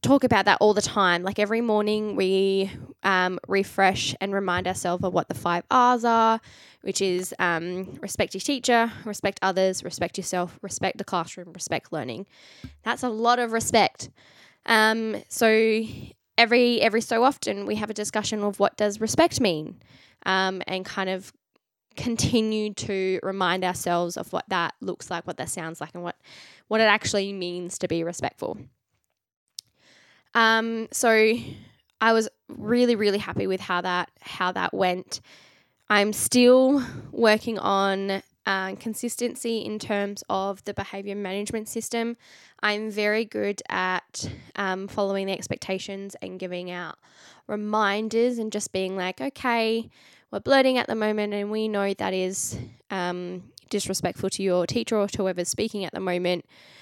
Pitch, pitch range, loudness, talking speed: 200 Hz, 185-225 Hz, -25 LUFS, 155 wpm